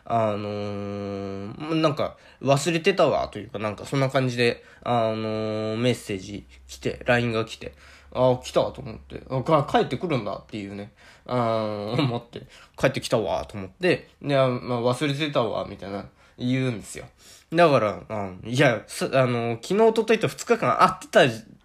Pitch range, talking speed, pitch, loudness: 105-135 Hz, 315 characters per minute, 120 Hz, -24 LUFS